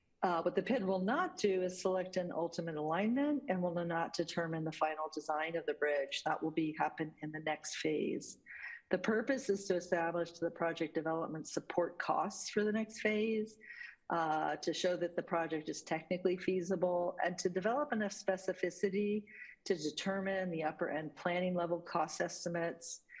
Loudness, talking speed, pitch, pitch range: -37 LUFS, 175 wpm, 175 Hz, 165-195 Hz